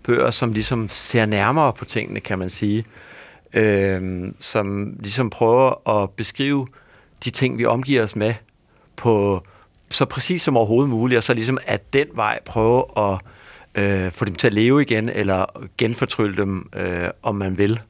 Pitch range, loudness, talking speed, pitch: 100-125 Hz, -20 LUFS, 170 wpm, 110 Hz